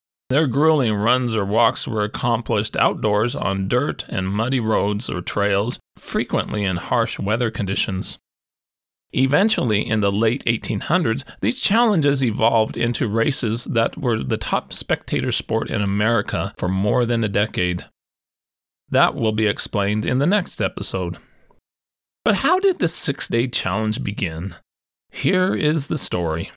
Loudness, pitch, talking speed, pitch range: -21 LUFS, 115 Hz, 140 wpm, 100-130 Hz